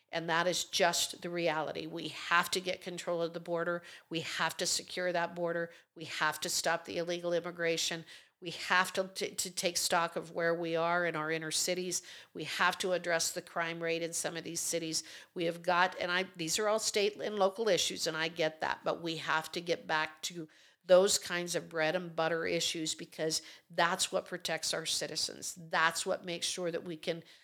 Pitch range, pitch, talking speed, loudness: 165-180 Hz, 170 Hz, 210 wpm, -33 LUFS